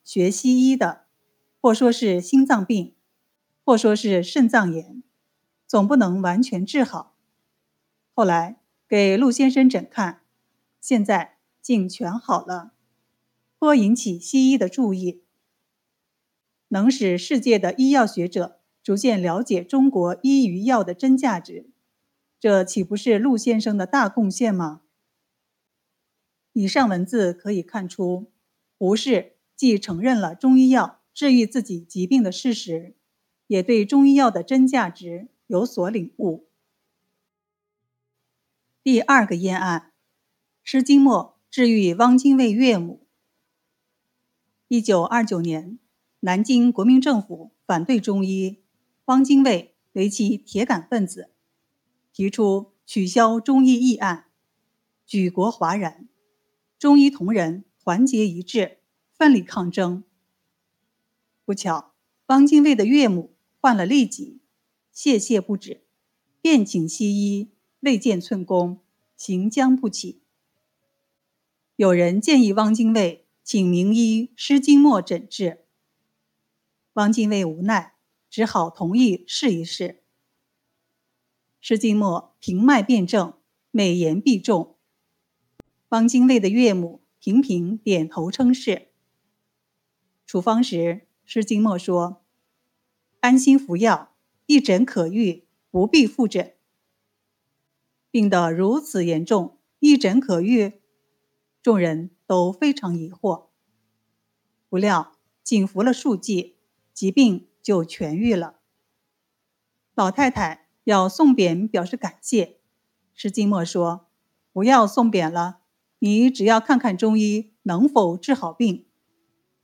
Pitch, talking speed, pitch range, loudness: 210 Hz, 170 characters per minute, 180-245 Hz, -20 LUFS